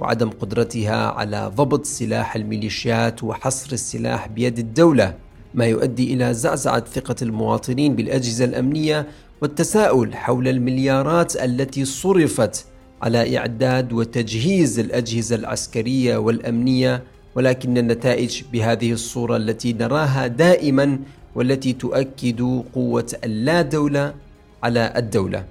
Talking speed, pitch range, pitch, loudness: 100 wpm, 115-135 Hz, 125 Hz, -20 LUFS